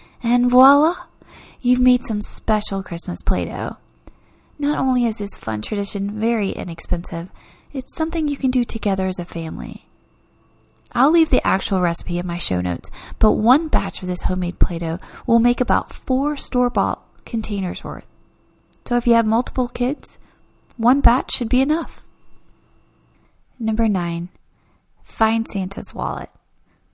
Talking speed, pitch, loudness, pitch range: 145 wpm, 225 Hz, -20 LUFS, 180-250 Hz